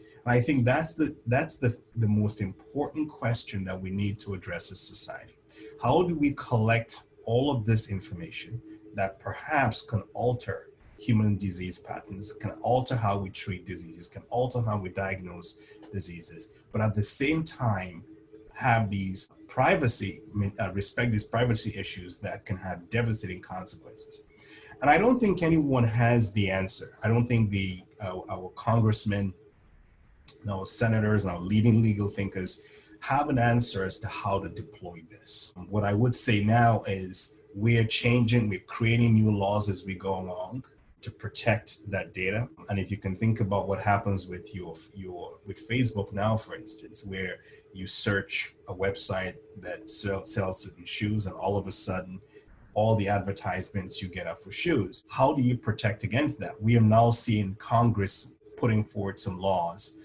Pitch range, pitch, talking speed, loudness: 95-115 Hz, 105 Hz, 170 wpm, -26 LUFS